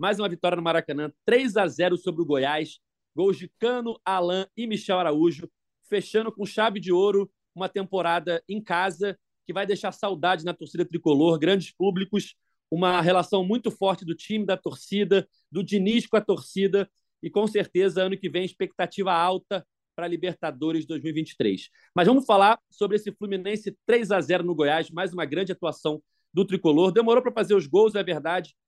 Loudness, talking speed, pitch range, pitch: -25 LUFS, 180 wpm, 170-205 Hz, 185 Hz